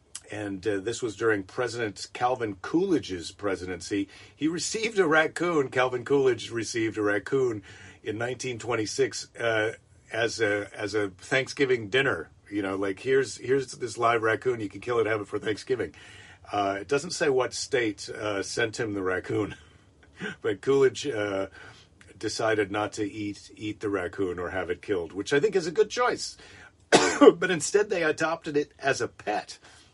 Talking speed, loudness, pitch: 165 wpm, -27 LUFS, 125 Hz